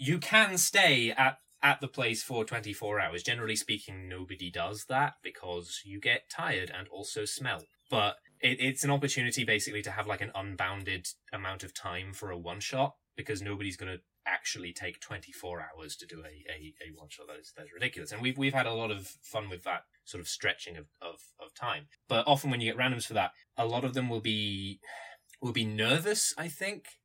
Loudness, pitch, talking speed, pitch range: -31 LUFS, 110 Hz, 210 wpm, 95-130 Hz